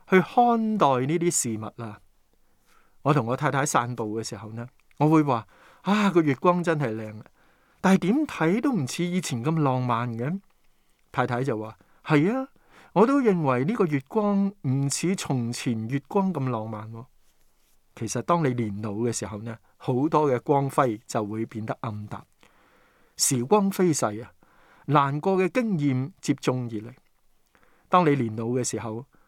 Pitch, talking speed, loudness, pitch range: 135 Hz, 220 characters per minute, -25 LUFS, 115-175 Hz